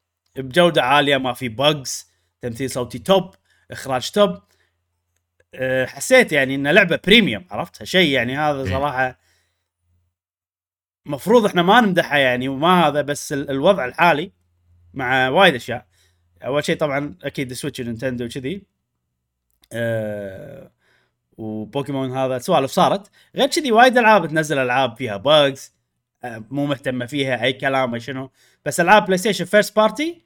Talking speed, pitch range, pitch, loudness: 130 wpm, 105-155 Hz, 130 Hz, -18 LUFS